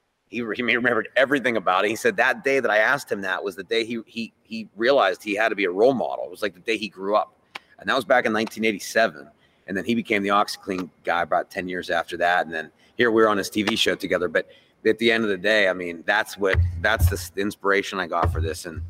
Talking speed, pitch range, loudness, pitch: 265 wpm, 90-110 Hz, -22 LUFS, 100 Hz